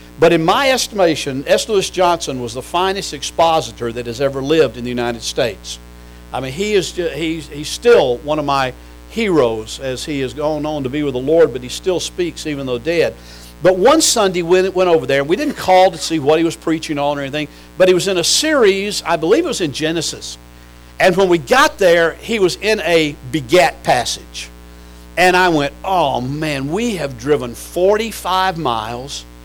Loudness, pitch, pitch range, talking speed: -16 LUFS, 155 Hz, 130-185 Hz, 205 wpm